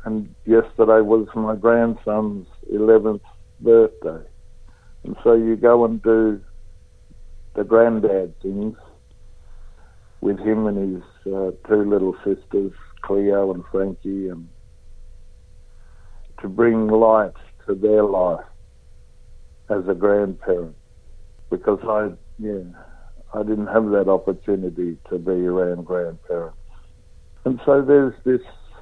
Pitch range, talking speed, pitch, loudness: 90-110 Hz, 110 wpm, 100 Hz, -20 LUFS